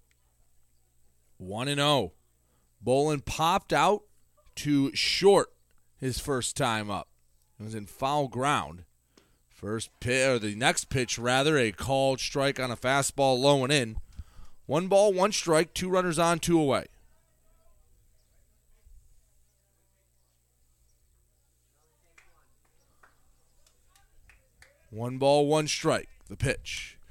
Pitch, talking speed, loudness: 110 Hz, 110 wpm, -27 LUFS